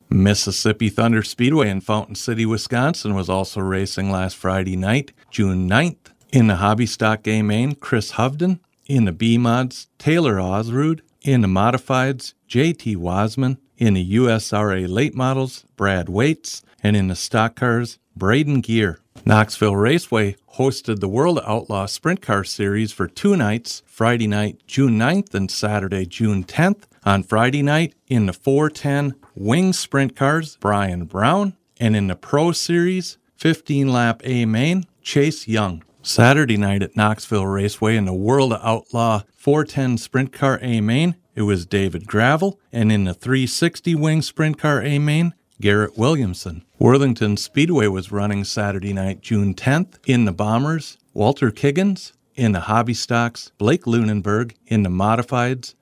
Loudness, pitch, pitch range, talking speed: -19 LUFS, 115 Hz, 105-140 Hz, 155 wpm